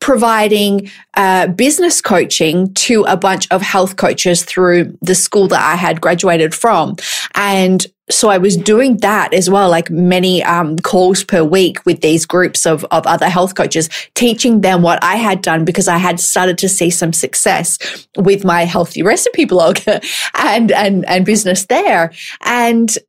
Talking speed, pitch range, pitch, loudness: 170 wpm, 175-205 Hz, 185 Hz, -12 LUFS